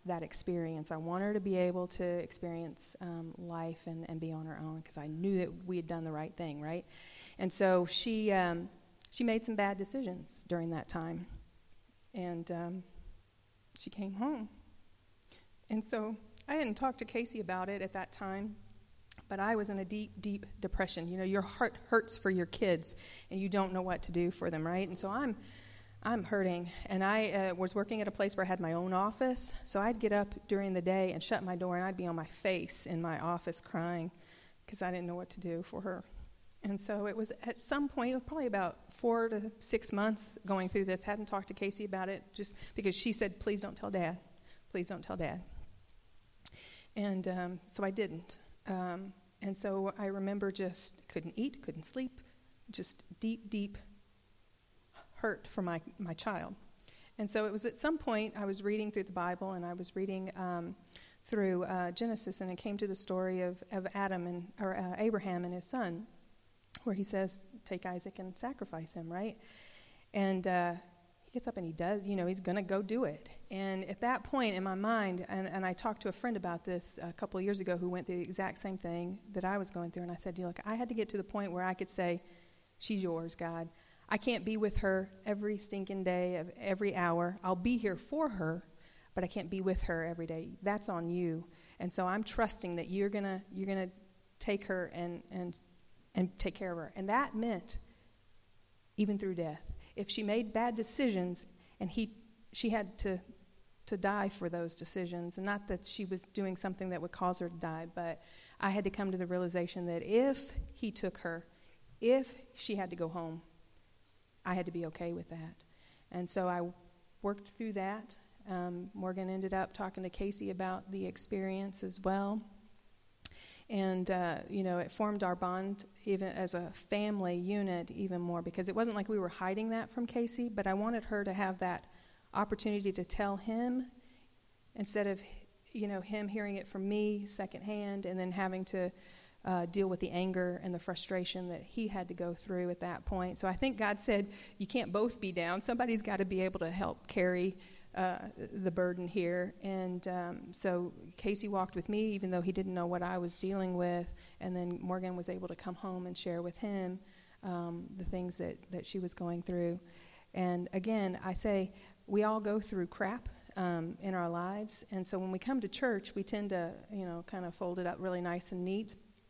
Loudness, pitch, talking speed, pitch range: -38 LUFS, 190 Hz, 210 wpm, 175-205 Hz